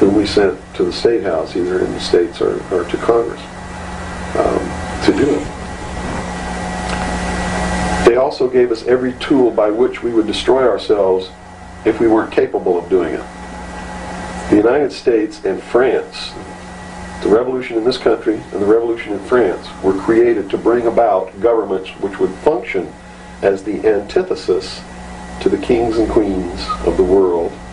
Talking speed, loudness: 160 wpm, -16 LUFS